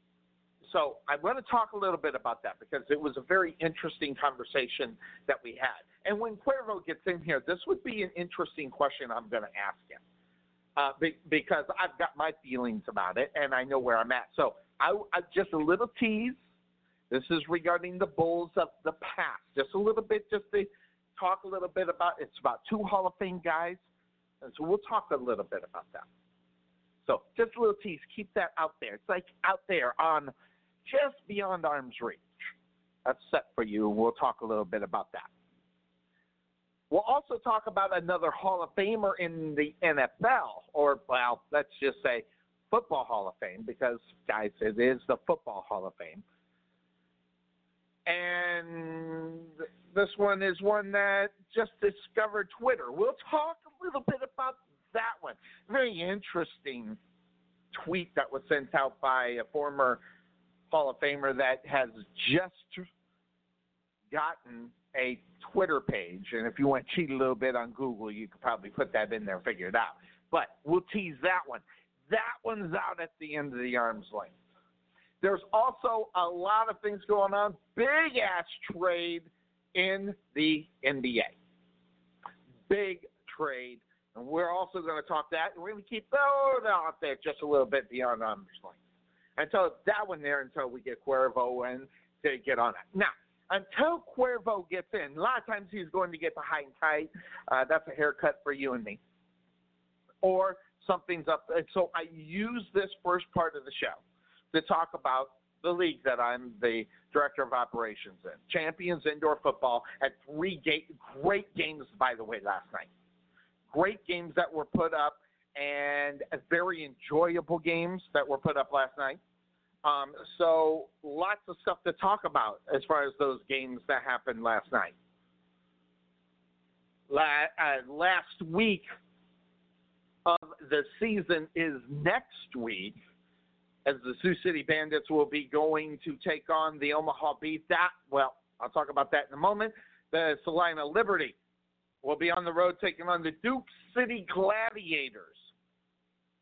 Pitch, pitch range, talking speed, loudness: 155 Hz, 120-190 Hz, 170 wpm, -31 LUFS